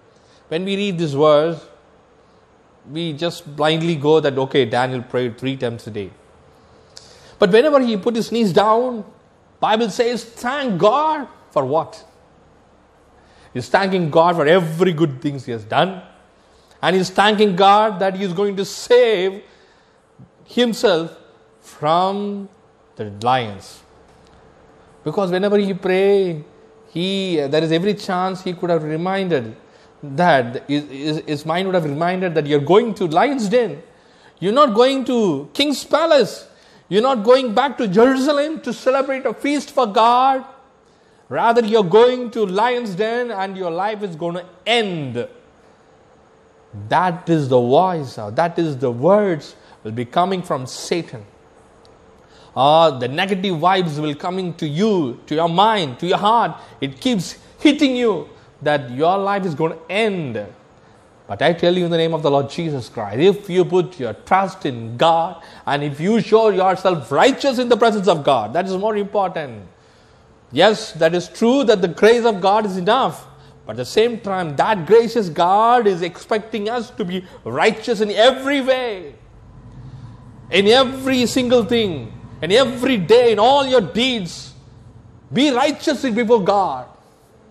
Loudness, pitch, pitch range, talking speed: -17 LUFS, 190 Hz, 155-230 Hz, 160 wpm